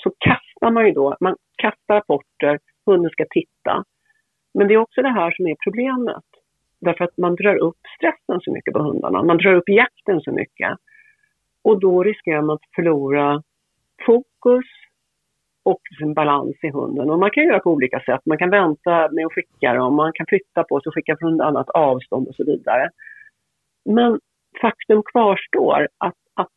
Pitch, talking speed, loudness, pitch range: 185 Hz, 180 wpm, -19 LUFS, 160-225 Hz